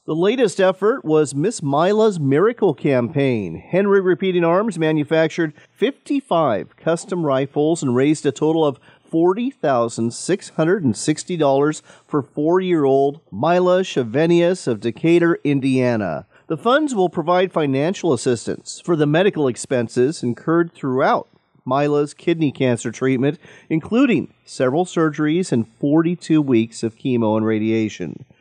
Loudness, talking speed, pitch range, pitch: -19 LUFS, 115 wpm, 130-175 Hz, 155 Hz